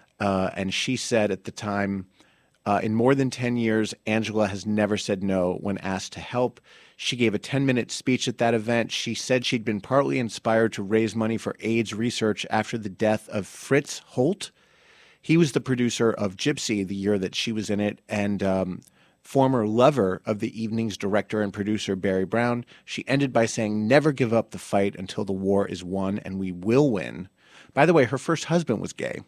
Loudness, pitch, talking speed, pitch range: -25 LUFS, 110 Hz, 205 wpm, 100-120 Hz